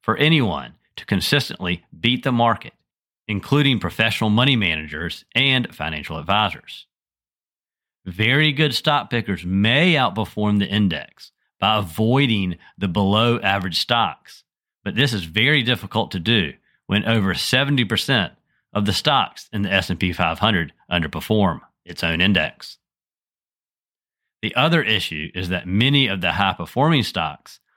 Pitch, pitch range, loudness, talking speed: 105 Hz, 90-120 Hz, -20 LUFS, 130 wpm